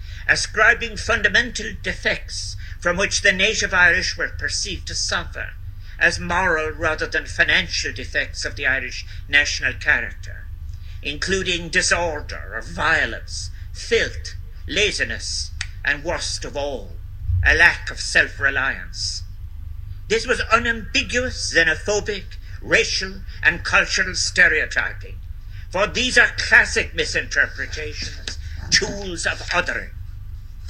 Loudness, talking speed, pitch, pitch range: -19 LUFS, 105 wpm, 90 Hz, 85-100 Hz